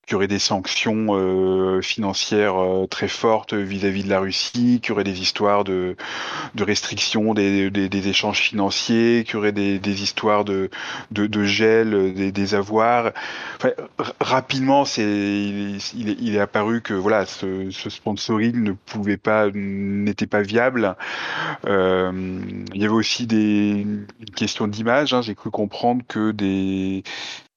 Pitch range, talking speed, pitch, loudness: 100-110 Hz, 145 wpm, 100 Hz, -21 LUFS